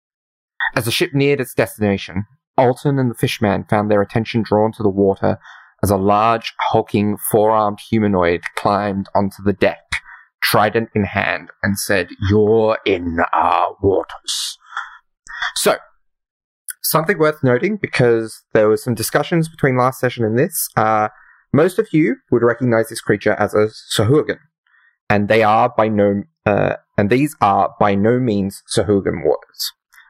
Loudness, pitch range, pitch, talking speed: -17 LUFS, 100-125 Hz, 110 Hz, 150 wpm